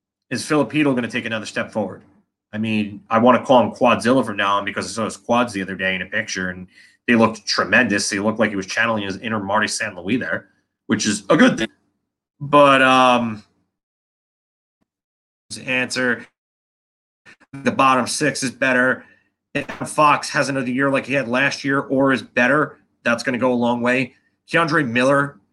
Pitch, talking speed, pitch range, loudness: 120 Hz, 195 wpm, 105-135 Hz, -19 LUFS